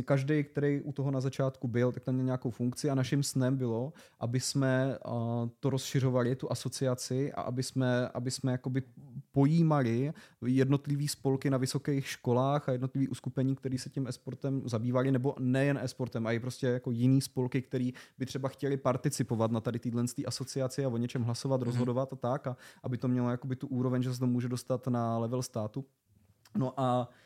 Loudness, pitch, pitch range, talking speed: -32 LUFS, 130 Hz, 125-135 Hz, 185 wpm